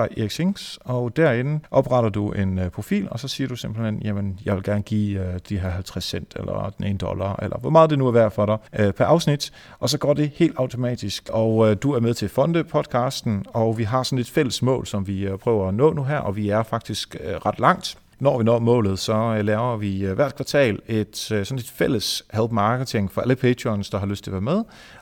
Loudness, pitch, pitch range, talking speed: -22 LUFS, 115 Hz, 105-130 Hz, 225 wpm